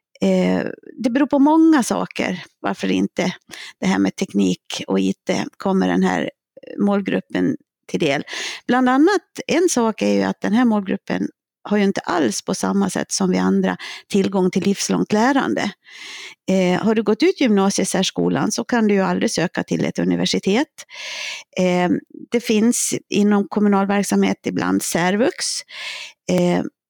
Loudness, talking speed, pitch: -19 LUFS, 145 wpm, 195 Hz